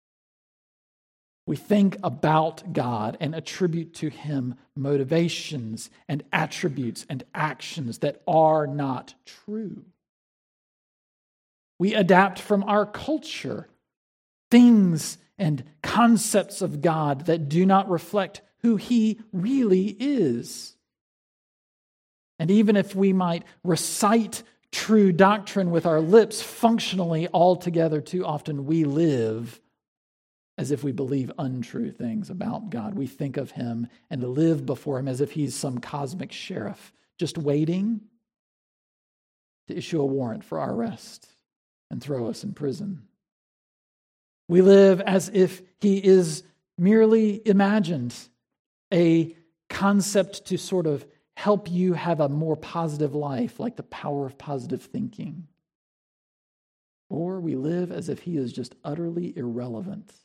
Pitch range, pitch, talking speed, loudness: 145-195 Hz, 170 Hz, 125 wpm, -24 LUFS